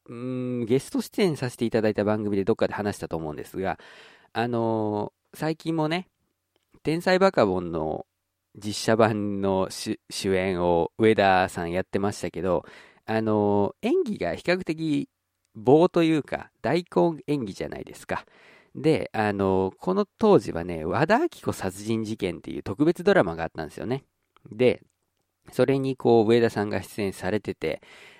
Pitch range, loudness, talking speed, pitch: 95-155 Hz, -25 LUFS, 305 characters per minute, 110 Hz